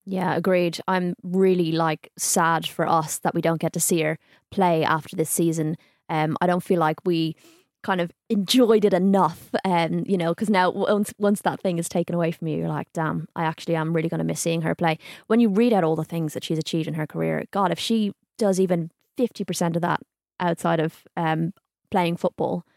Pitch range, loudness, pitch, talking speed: 160-190 Hz, -23 LUFS, 170 Hz, 220 wpm